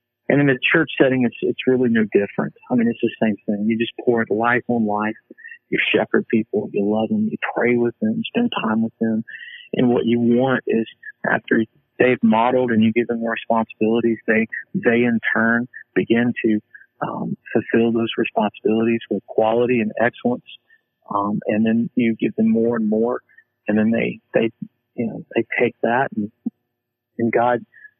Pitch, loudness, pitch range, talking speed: 120 Hz, -20 LUFS, 115-125 Hz, 185 wpm